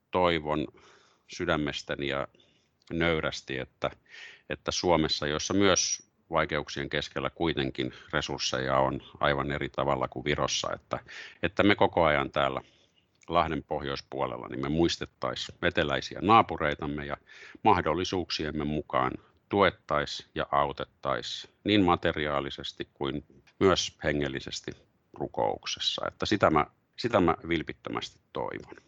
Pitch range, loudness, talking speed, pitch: 70-80 Hz, -29 LUFS, 105 wpm, 75 Hz